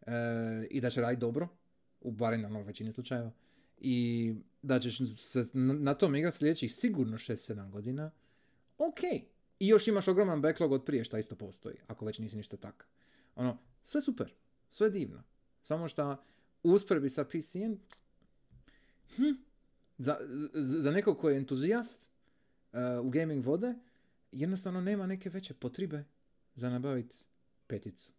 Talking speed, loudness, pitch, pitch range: 140 wpm, -34 LUFS, 135 Hz, 120-190 Hz